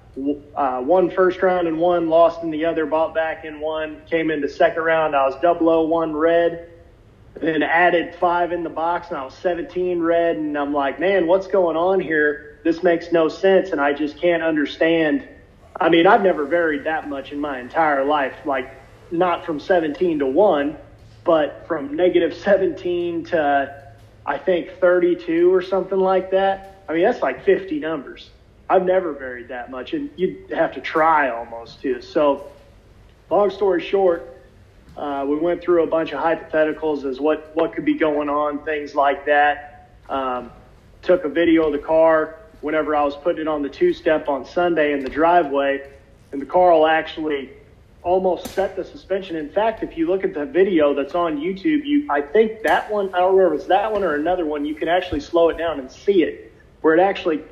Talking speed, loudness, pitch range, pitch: 195 wpm, -20 LUFS, 145-180 Hz, 160 Hz